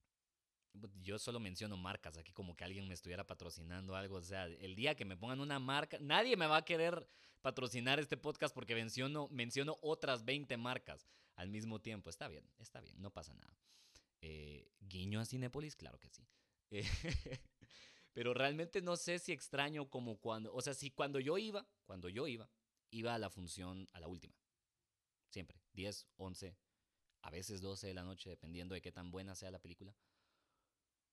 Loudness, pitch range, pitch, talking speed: -44 LUFS, 95-135 Hz, 105 Hz, 180 wpm